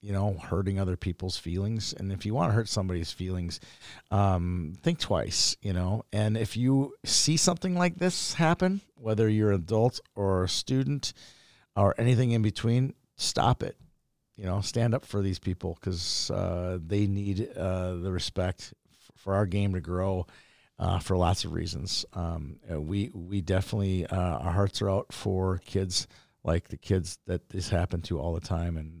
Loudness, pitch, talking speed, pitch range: -29 LUFS, 95 Hz, 175 wpm, 90-110 Hz